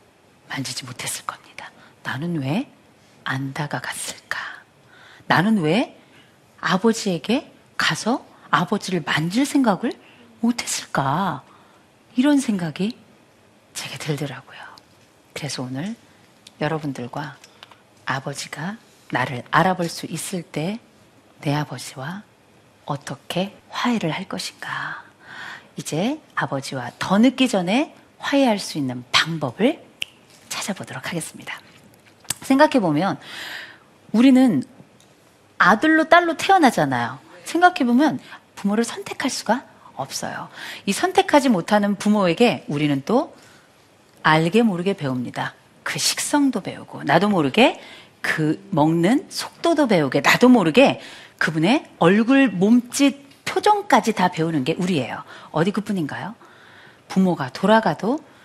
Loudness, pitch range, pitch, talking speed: -21 LUFS, 150-250 Hz, 185 Hz, 245 characters per minute